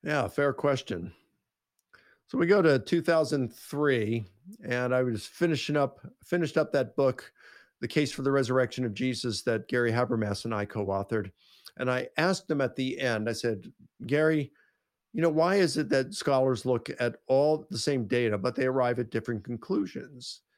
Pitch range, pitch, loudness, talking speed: 120-150 Hz, 130 Hz, -28 LUFS, 170 wpm